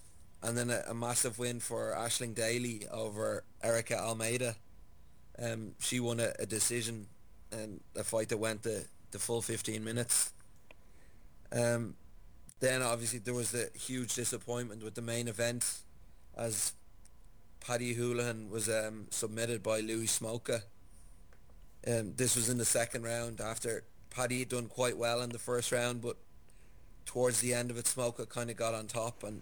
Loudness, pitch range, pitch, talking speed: -35 LUFS, 110-120 Hz, 115 Hz, 165 wpm